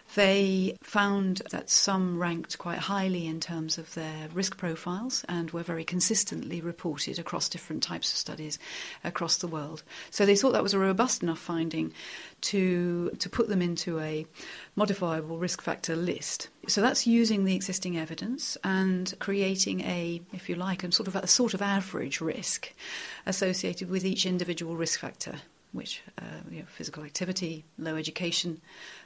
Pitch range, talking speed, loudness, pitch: 165-195 Hz, 165 wpm, -29 LUFS, 180 Hz